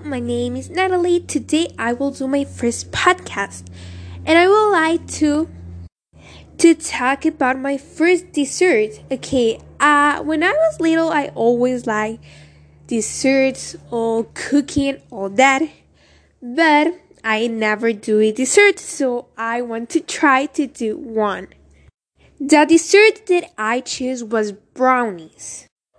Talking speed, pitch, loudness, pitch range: 130 wpm, 265 Hz, -17 LUFS, 225-320 Hz